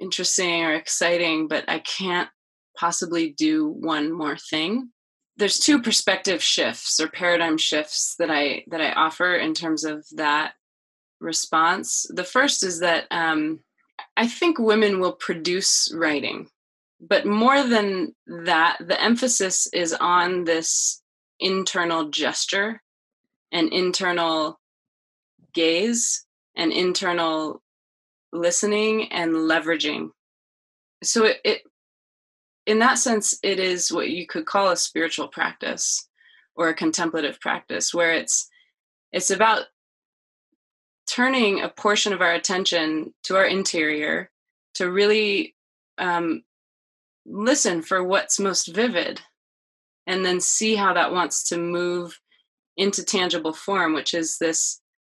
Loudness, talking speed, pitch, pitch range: -22 LUFS, 120 wpm, 180 Hz, 165-215 Hz